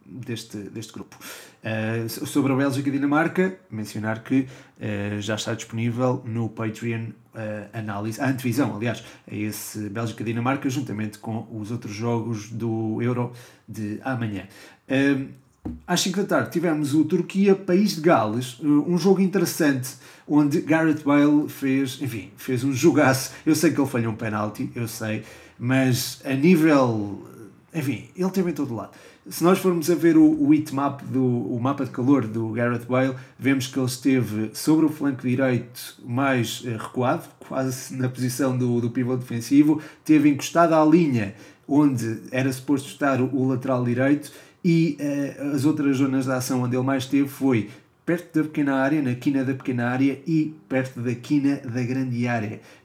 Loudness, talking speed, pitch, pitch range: -23 LUFS, 170 wpm, 130 Hz, 115-145 Hz